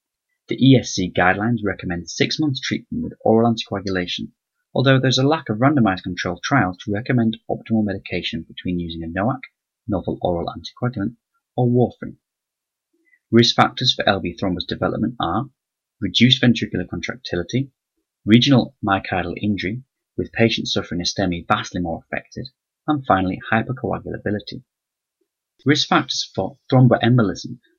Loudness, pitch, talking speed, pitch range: -20 LUFS, 110 Hz, 125 wpm, 95-125 Hz